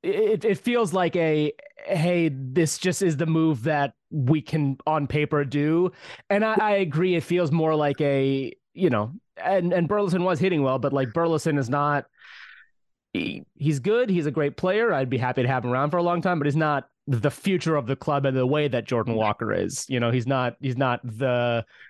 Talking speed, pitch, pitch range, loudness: 215 wpm, 150 Hz, 135-175 Hz, -24 LUFS